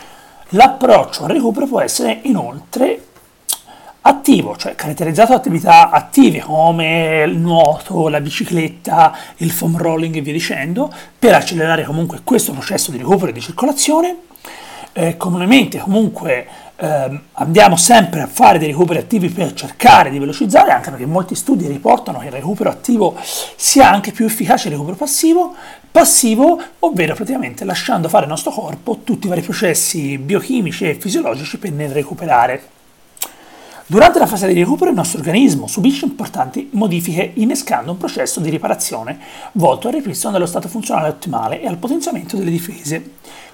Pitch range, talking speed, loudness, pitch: 165-255 Hz, 150 wpm, -14 LUFS, 195 Hz